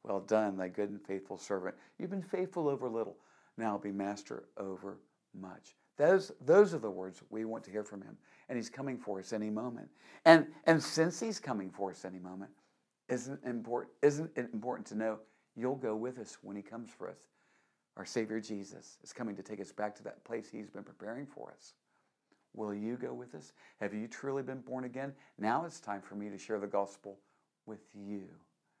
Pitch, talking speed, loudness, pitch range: 110 Hz, 205 wpm, -36 LUFS, 100-130 Hz